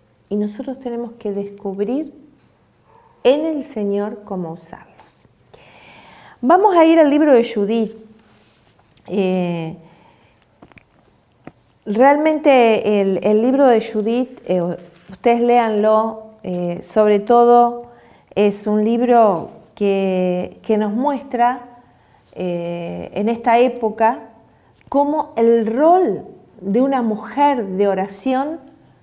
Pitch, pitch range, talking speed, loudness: 220 Hz, 195-250 Hz, 100 wpm, -17 LUFS